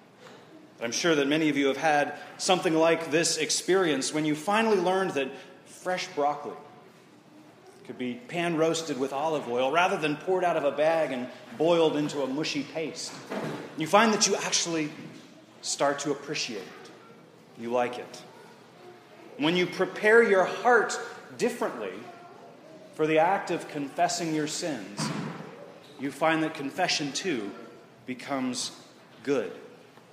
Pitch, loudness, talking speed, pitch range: 155 Hz, -27 LUFS, 140 wpm, 145-180 Hz